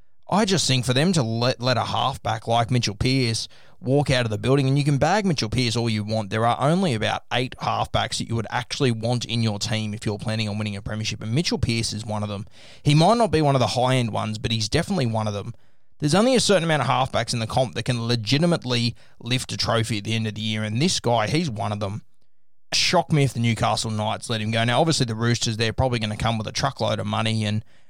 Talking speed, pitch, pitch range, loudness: 265 wpm, 120 Hz, 110-135 Hz, -22 LUFS